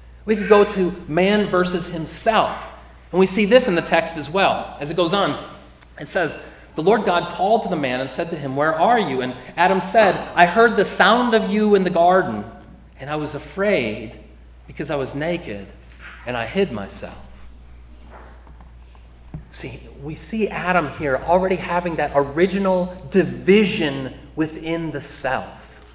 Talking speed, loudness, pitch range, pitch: 170 wpm, -19 LUFS, 135-190 Hz, 170 Hz